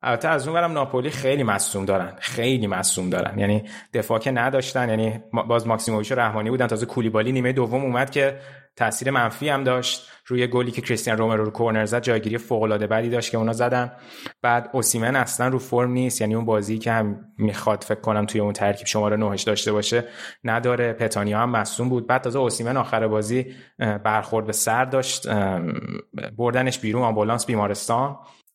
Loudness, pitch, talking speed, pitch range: -23 LUFS, 115 Hz, 180 wpm, 110-125 Hz